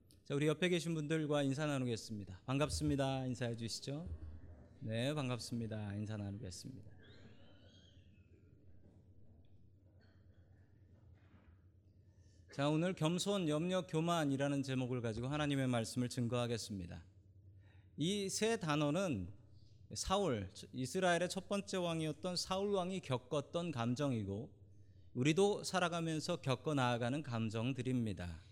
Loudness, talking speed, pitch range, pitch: -39 LUFS, 265 characters per minute, 100-150 Hz, 120 Hz